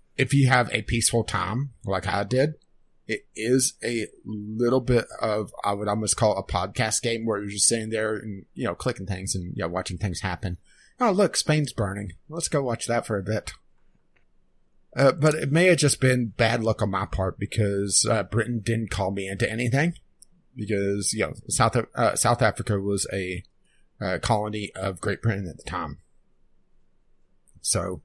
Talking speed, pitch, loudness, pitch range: 190 wpm, 110 Hz, -25 LUFS, 100-120 Hz